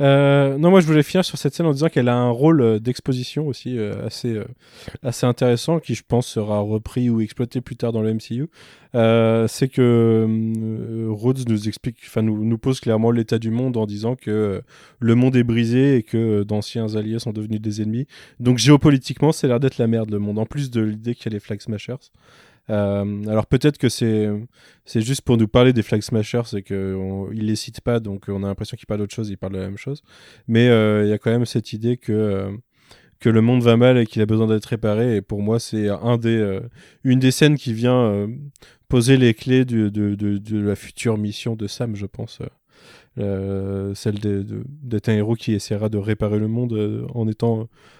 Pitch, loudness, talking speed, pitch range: 115 Hz, -20 LUFS, 230 wpm, 105-125 Hz